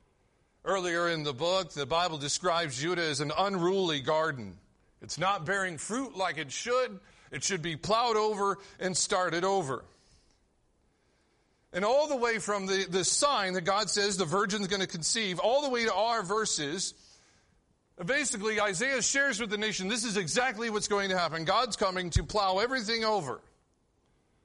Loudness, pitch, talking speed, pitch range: -29 LUFS, 195 Hz, 165 wpm, 175-220 Hz